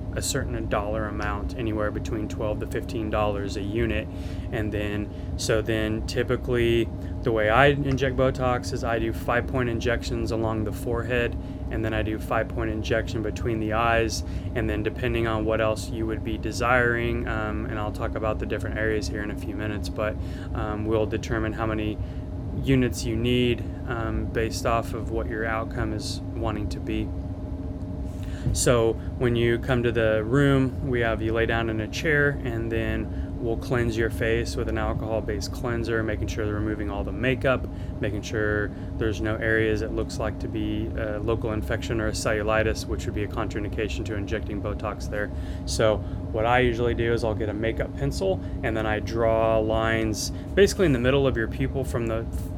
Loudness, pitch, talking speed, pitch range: -26 LUFS, 110 Hz, 190 wpm, 95-115 Hz